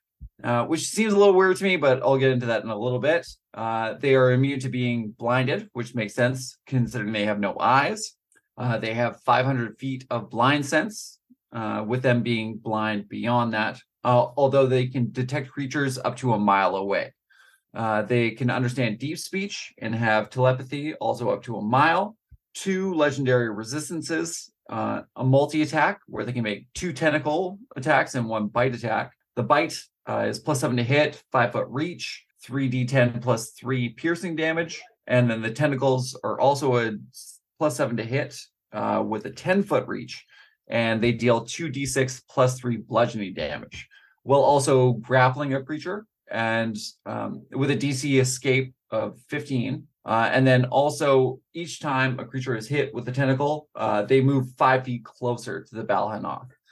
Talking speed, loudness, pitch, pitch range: 175 wpm, -24 LUFS, 130 Hz, 120-145 Hz